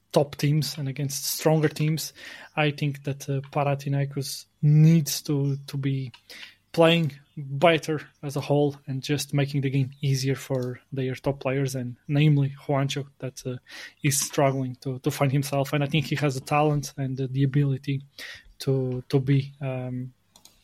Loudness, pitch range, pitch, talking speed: -26 LUFS, 135-145 Hz, 140 Hz, 165 wpm